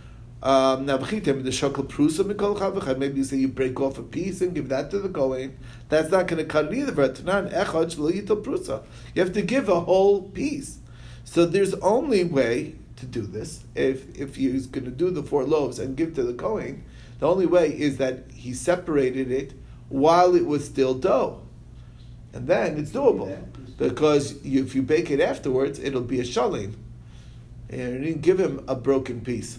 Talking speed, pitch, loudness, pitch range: 175 wpm, 135 Hz, -24 LUFS, 125-170 Hz